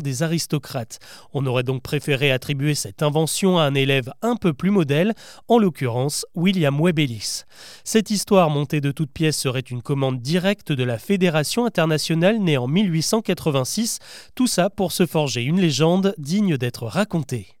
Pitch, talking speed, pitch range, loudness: 155 Hz, 160 wpm, 135-190 Hz, -21 LUFS